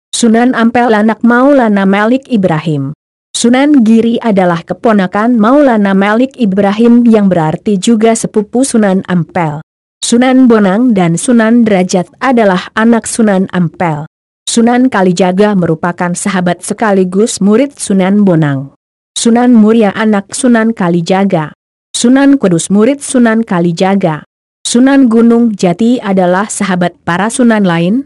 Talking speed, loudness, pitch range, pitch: 115 wpm, -9 LUFS, 185-235 Hz, 210 Hz